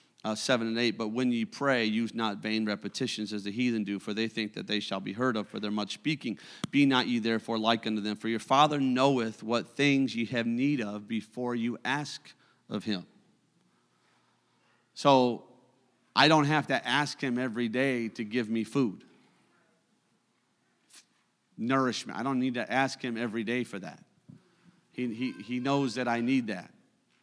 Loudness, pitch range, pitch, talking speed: -29 LUFS, 110-130 Hz, 120 Hz, 185 wpm